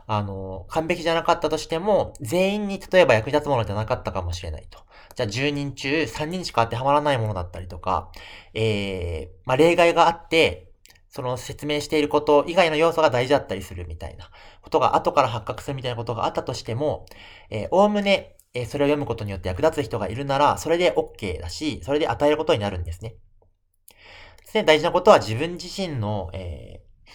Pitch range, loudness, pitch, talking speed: 100-160 Hz, -22 LUFS, 135 Hz, 410 characters per minute